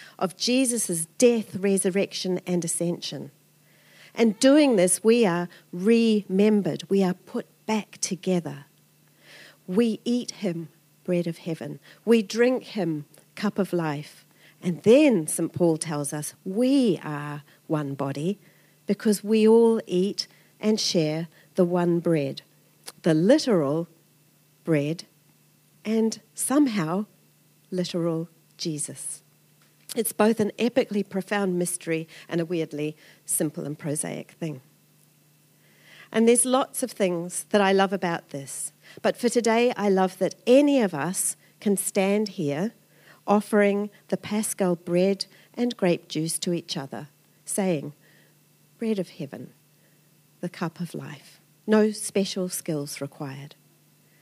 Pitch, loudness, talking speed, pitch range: 180 Hz, -25 LUFS, 125 wpm, 160-210 Hz